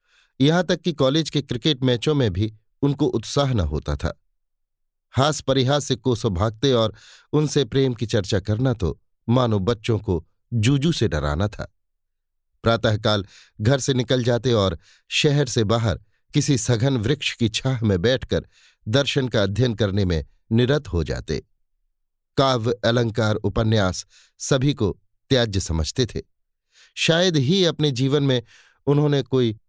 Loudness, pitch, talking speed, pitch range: -22 LUFS, 115 Hz, 145 wpm, 100-135 Hz